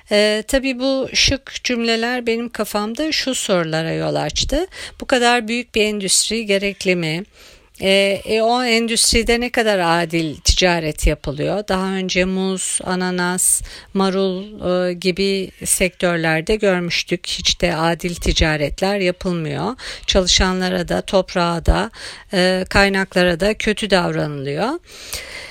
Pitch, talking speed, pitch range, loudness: 195 Hz, 120 wpm, 180-225 Hz, -18 LUFS